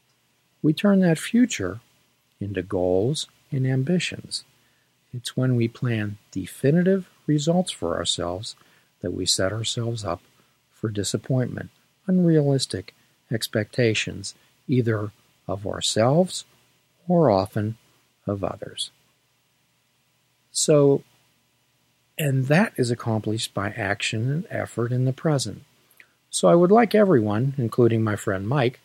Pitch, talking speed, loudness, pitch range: 120 Hz, 110 wpm, -23 LUFS, 105-150 Hz